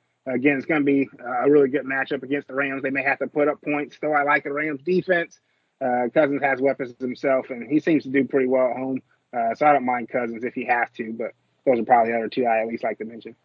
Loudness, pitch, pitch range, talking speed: -23 LUFS, 135 Hz, 130-145 Hz, 275 wpm